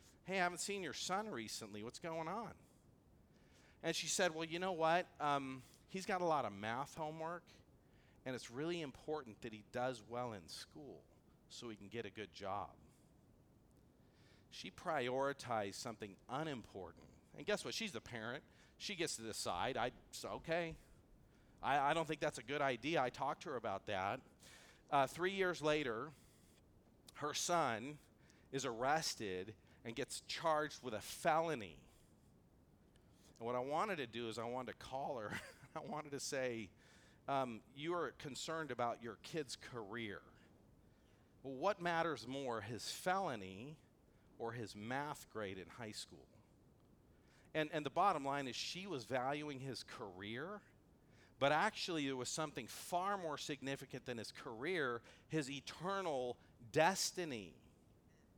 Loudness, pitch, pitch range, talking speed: -43 LUFS, 135 Hz, 115-160 Hz, 155 wpm